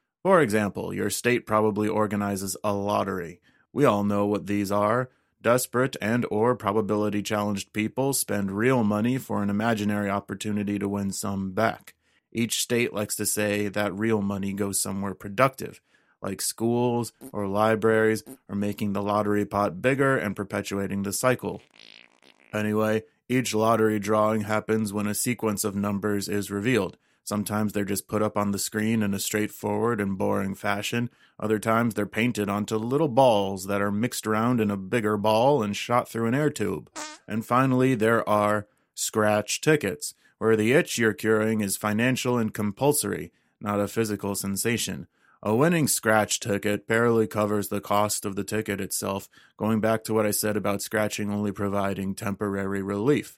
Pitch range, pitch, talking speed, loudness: 100-115 Hz, 105 Hz, 165 wpm, -25 LUFS